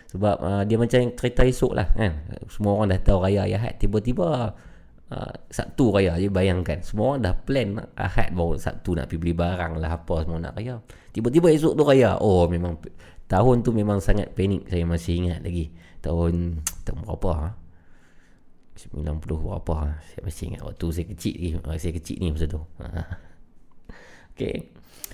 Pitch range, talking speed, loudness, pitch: 85-105 Hz, 165 wpm, -24 LUFS, 90 Hz